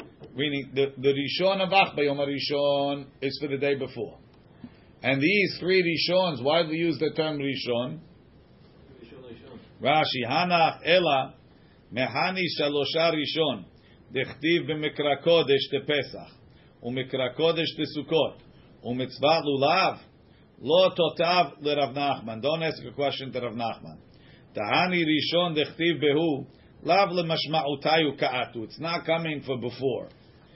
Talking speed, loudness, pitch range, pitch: 120 wpm, -25 LUFS, 135-160 Hz, 145 Hz